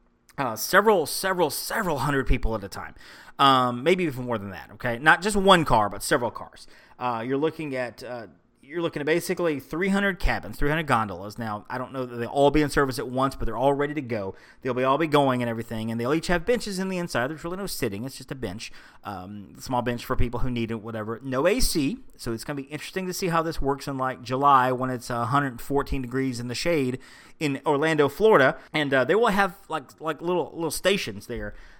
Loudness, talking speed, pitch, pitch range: -25 LUFS, 235 wpm, 135 Hz, 120-160 Hz